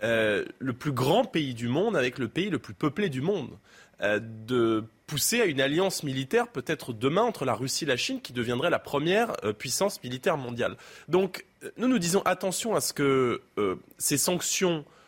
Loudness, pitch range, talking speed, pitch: -27 LUFS, 125-190 Hz, 195 wpm, 145 Hz